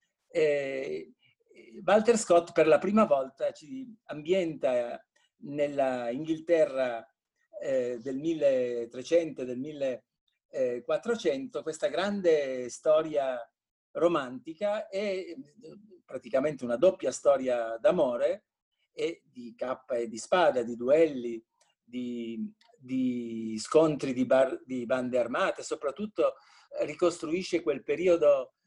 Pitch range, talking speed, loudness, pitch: 130-210 Hz, 90 wpm, -29 LUFS, 155 Hz